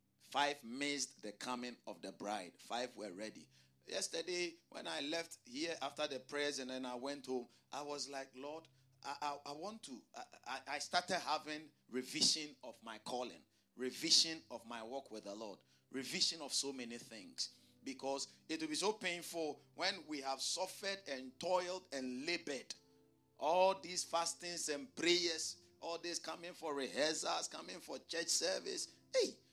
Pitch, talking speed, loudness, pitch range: 145 Hz, 165 wpm, -41 LUFS, 130-170 Hz